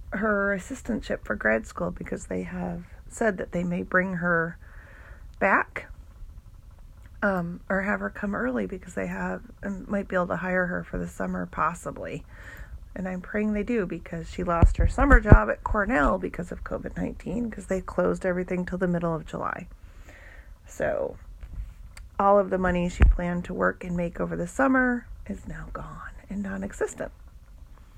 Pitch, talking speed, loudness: 175 Hz, 175 wpm, -27 LUFS